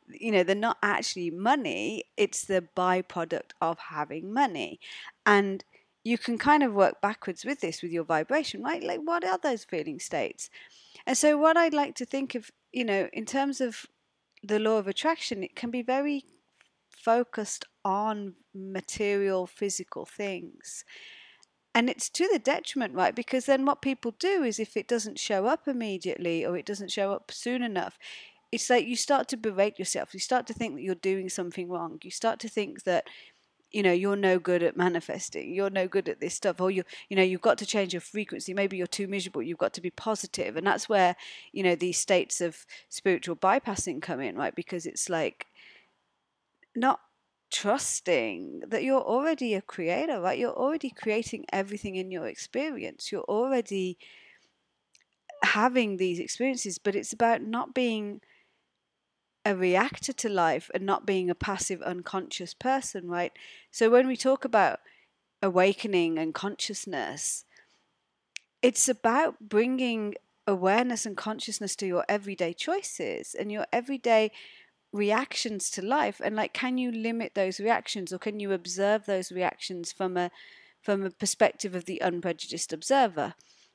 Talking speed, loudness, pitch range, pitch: 170 wpm, -29 LUFS, 185-250 Hz, 210 Hz